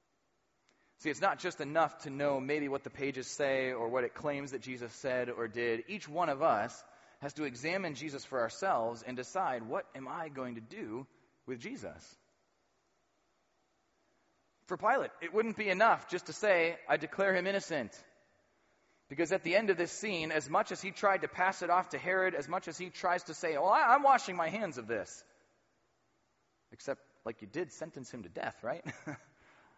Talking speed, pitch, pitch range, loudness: 195 wpm, 160 Hz, 140-185 Hz, -34 LUFS